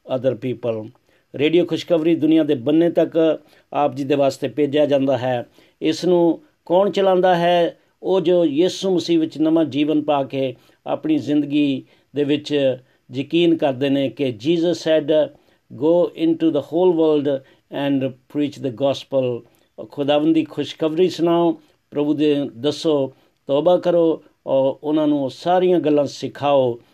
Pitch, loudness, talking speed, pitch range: 150 Hz, -19 LUFS, 135 wpm, 135-165 Hz